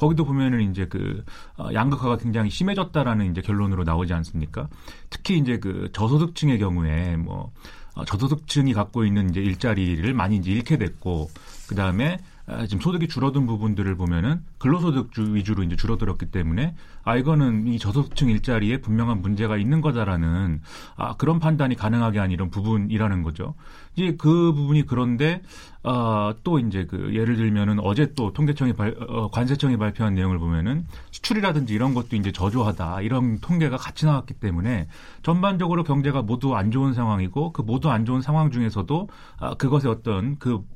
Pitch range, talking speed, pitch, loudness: 100-140 Hz, 380 characters per minute, 115 Hz, -23 LUFS